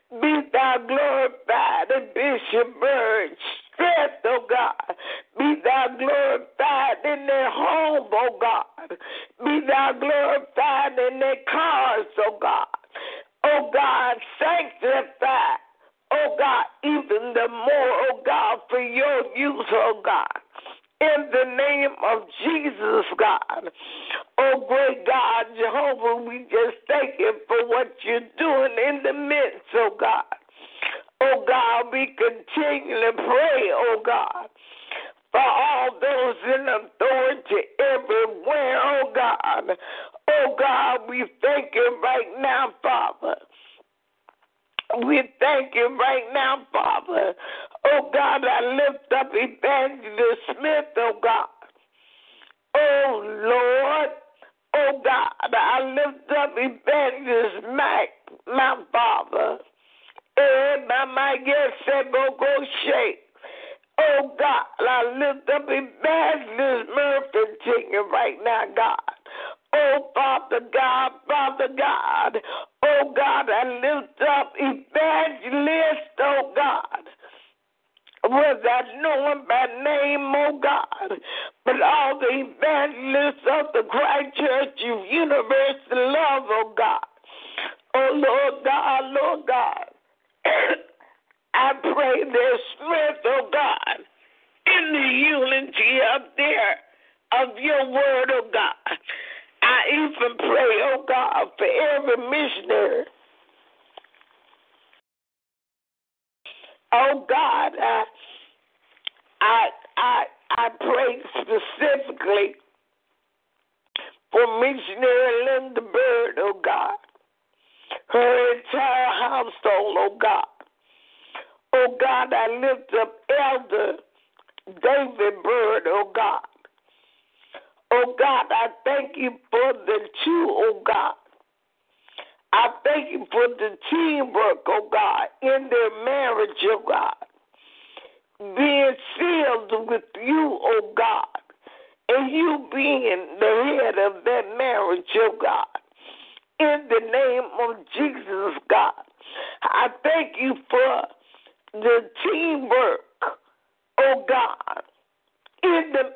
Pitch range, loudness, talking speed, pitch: 260-405 Hz, -22 LUFS, 110 wpm, 285 Hz